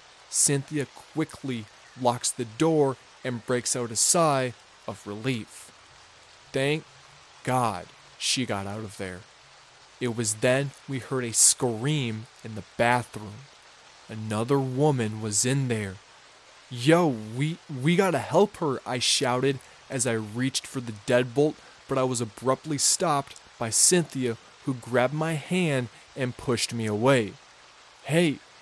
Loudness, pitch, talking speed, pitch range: -26 LUFS, 125 Hz, 135 wpm, 115-140 Hz